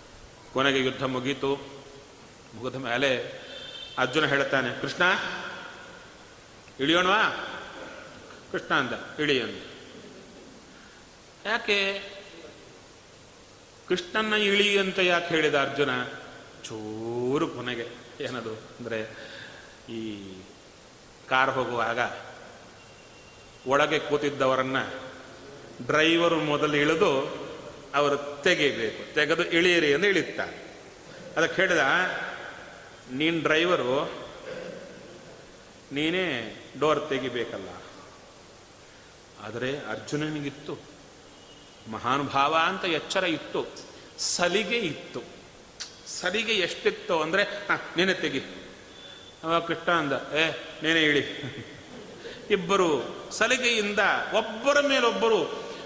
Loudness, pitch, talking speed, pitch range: -26 LUFS, 145 Hz, 70 wpm, 125-185 Hz